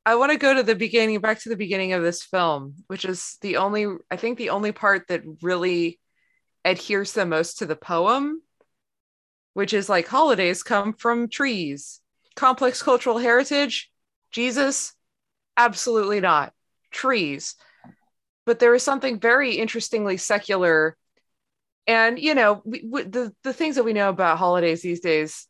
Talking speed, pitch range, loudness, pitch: 160 wpm, 180-240 Hz, -22 LUFS, 210 Hz